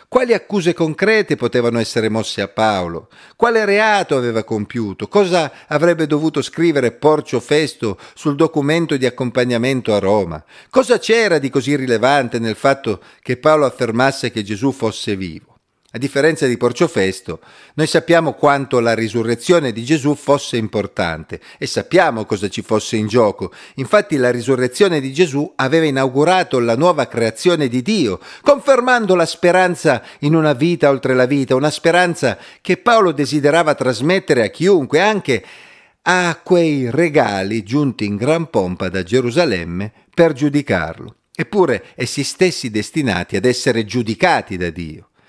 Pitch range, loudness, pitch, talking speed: 115-165 Hz, -16 LUFS, 140 Hz, 145 wpm